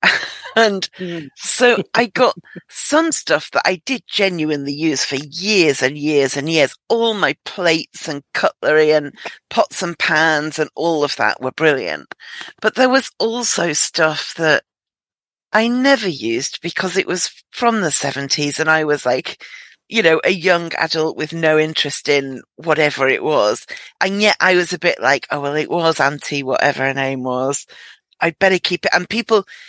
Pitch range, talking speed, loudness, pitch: 145-195 Hz, 170 wpm, -16 LUFS, 160 Hz